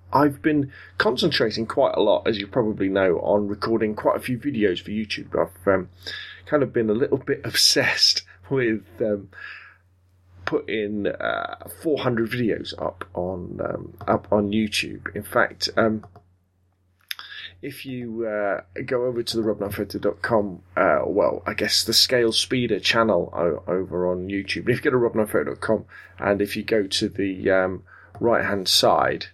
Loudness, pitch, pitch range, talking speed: -22 LUFS, 105 Hz, 95-115 Hz, 155 wpm